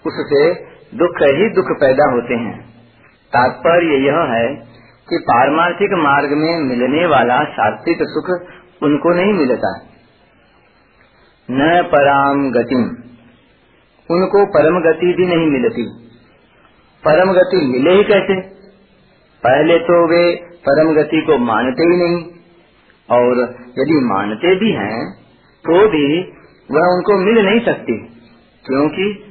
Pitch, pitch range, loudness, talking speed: 165 Hz, 130-185 Hz, -14 LUFS, 115 wpm